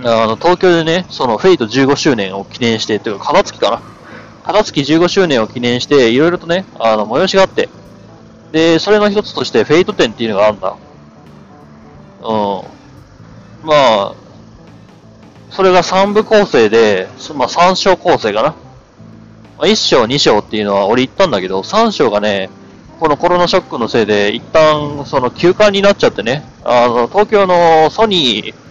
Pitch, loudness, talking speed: 155 Hz, -12 LUFS, 315 characters per minute